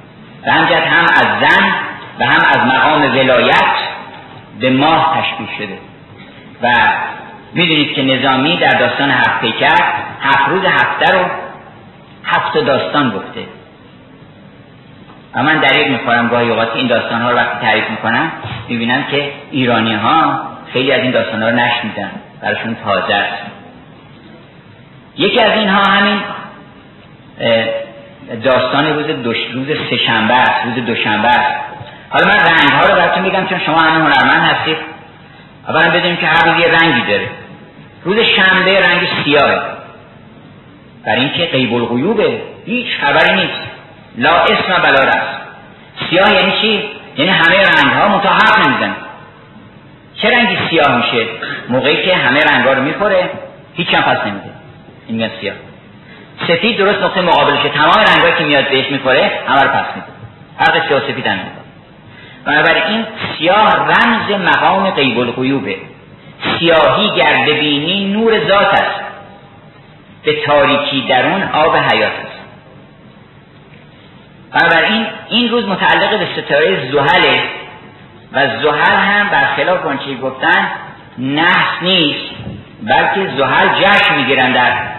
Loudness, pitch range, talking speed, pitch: -11 LUFS, 125-190 Hz, 130 wpm, 155 Hz